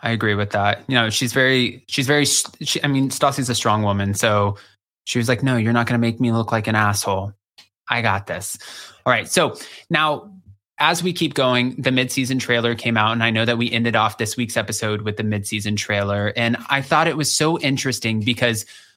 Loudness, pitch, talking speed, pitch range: -19 LUFS, 120 Hz, 220 wpm, 105-130 Hz